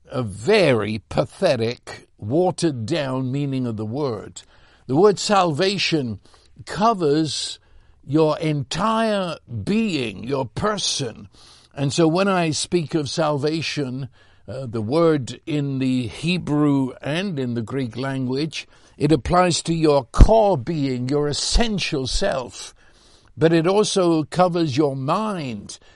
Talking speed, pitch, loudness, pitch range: 120 wpm, 150 Hz, -21 LUFS, 130-170 Hz